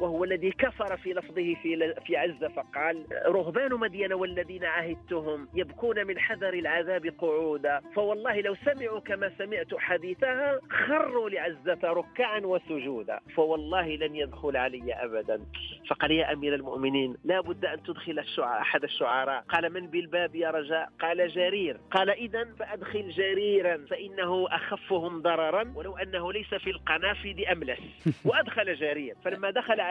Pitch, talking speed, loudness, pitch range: 180 Hz, 140 wpm, -30 LUFS, 160-200 Hz